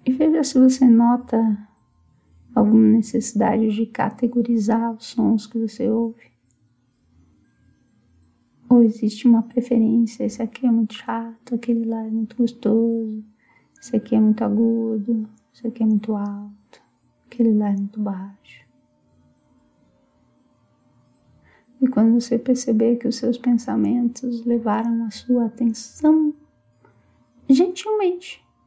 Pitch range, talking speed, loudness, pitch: 215-240 Hz, 115 wpm, -20 LUFS, 225 Hz